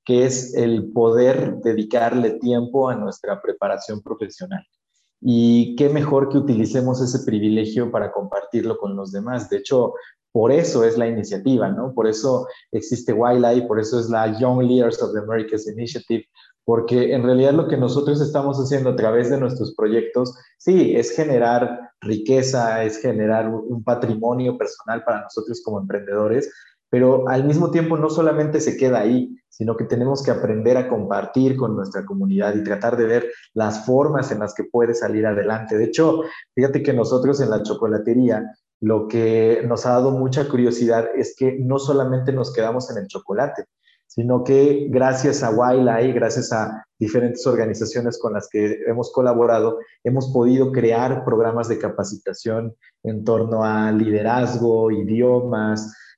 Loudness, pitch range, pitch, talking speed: -20 LUFS, 110-130 Hz, 120 Hz, 160 wpm